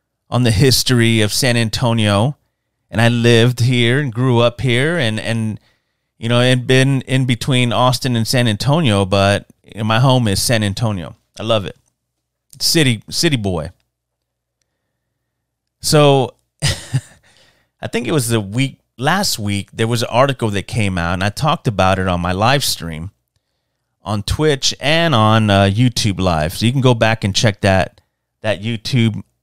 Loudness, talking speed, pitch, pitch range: -15 LUFS, 165 wpm, 115 Hz, 100-130 Hz